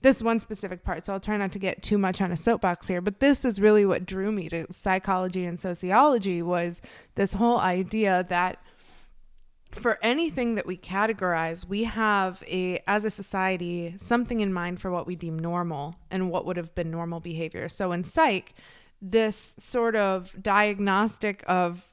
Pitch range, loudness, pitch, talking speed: 175-210 Hz, -26 LUFS, 190 Hz, 180 wpm